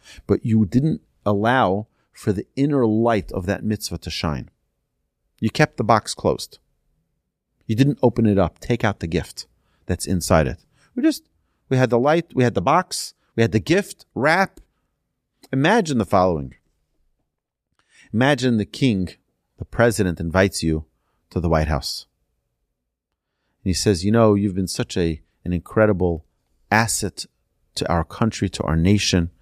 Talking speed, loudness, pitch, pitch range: 155 wpm, -21 LUFS, 100 Hz, 85-120 Hz